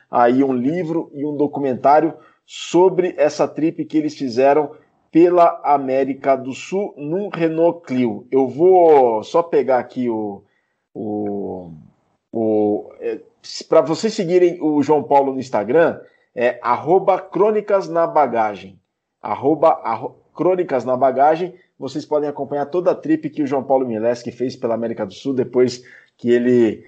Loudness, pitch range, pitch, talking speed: -18 LUFS, 125-170 Hz, 145 Hz, 145 wpm